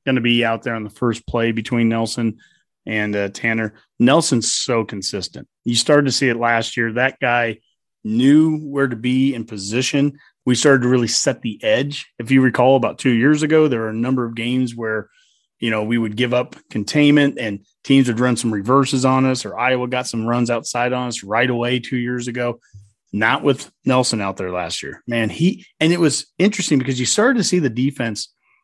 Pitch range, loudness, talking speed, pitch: 115-140 Hz, -18 LUFS, 210 wpm, 125 Hz